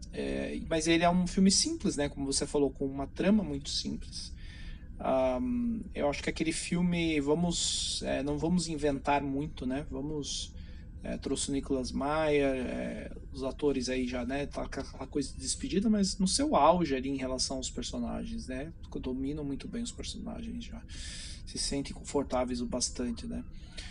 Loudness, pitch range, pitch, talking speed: -32 LUFS, 130-170 Hz, 140 Hz, 170 wpm